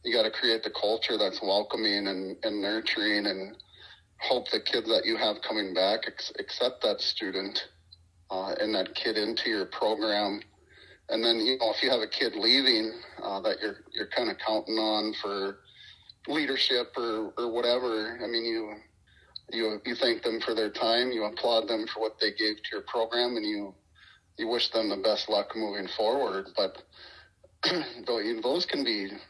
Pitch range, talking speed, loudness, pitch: 100-115 Hz, 180 wpm, -28 LUFS, 110 Hz